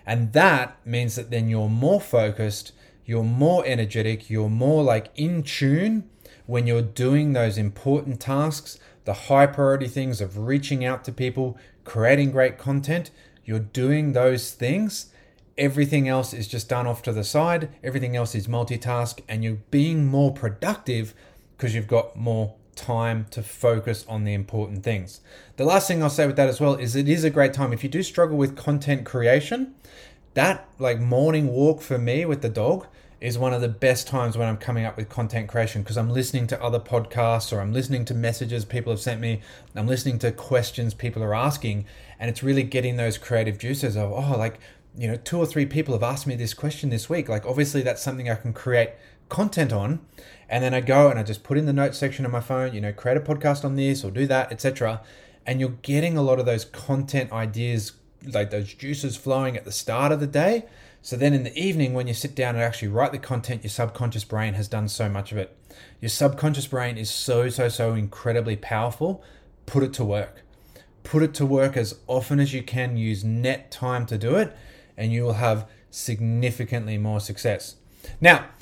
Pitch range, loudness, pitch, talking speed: 115-140 Hz, -24 LUFS, 125 Hz, 205 wpm